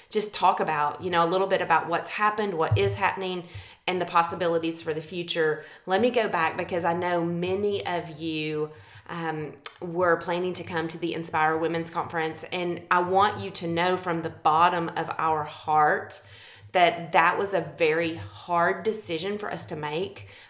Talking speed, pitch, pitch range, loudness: 185 wpm, 170 Hz, 160-180 Hz, -26 LUFS